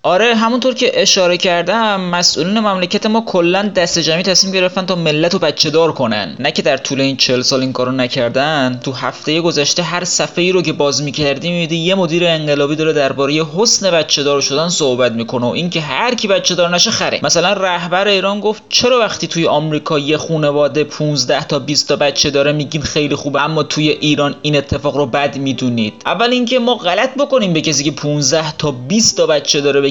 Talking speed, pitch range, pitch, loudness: 200 wpm, 145-185 Hz, 160 Hz, -13 LUFS